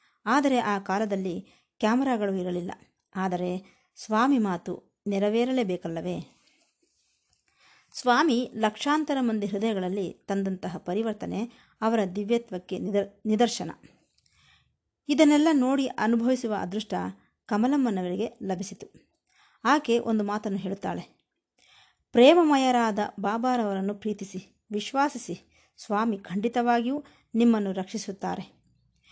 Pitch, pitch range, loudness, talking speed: 215 Hz, 195-245 Hz, -26 LUFS, 75 wpm